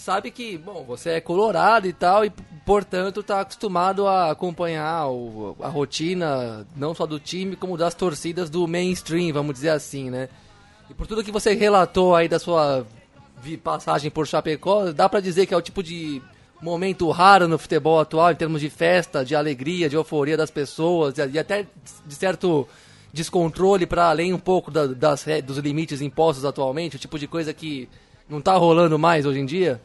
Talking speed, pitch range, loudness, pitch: 185 wpm, 145-180 Hz, -21 LUFS, 165 Hz